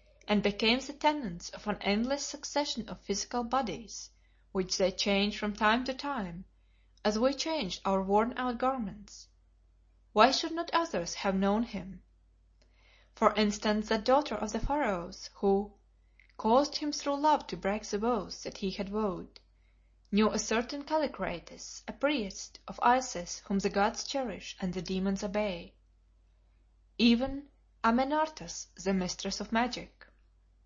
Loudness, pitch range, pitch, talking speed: -31 LUFS, 190-255 Hz, 210 Hz, 145 wpm